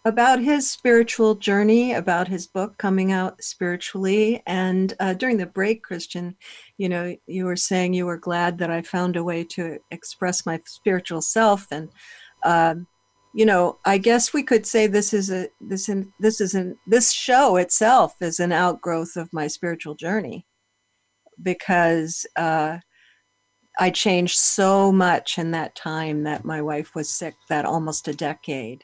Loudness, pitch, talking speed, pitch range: -21 LUFS, 180 Hz, 165 wpm, 165-205 Hz